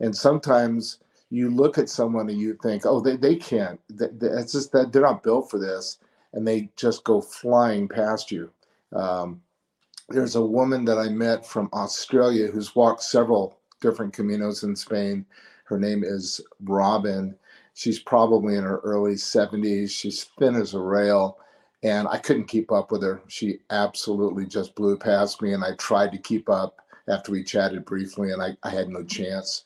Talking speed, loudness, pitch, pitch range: 180 wpm, -24 LUFS, 105 Hz, 95-115 Hz